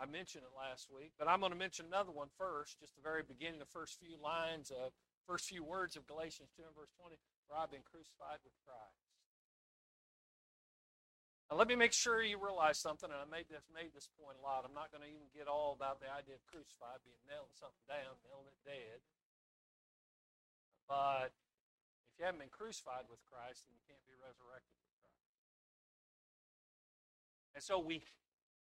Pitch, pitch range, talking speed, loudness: 150 Hz, 135-165 Hz, 190 wpm, -42 LUFS